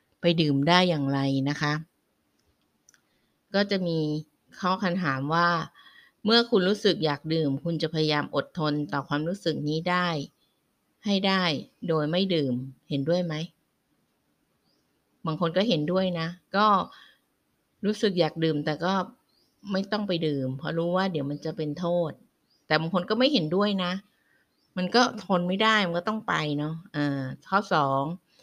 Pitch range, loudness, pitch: 150-190 Hz, -26 LUFS, 170 Hz